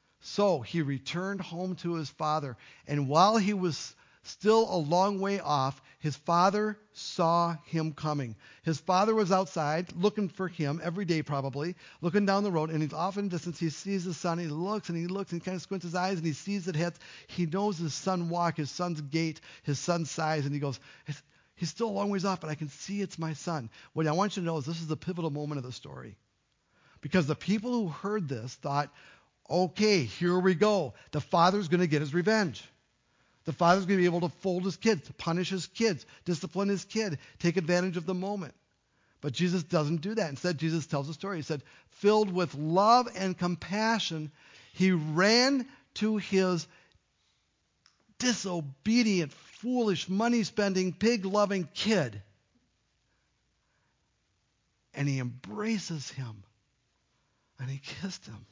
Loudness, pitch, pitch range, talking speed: -30 LUFS, 175 Hz, 150-195 Hz, 180 wpm